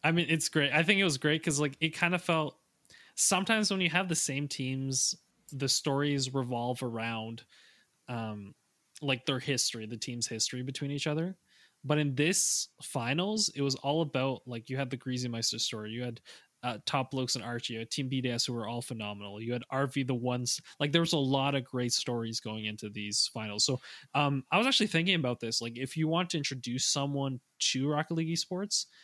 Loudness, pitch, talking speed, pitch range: -31 LUFS, 135 Hz, 210 wpm, 120-155 Hz